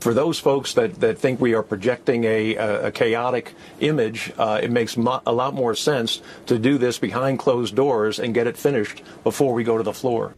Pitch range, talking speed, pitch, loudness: 110-130 Hz, 215 wpm, 120 Hz, -21 LUFS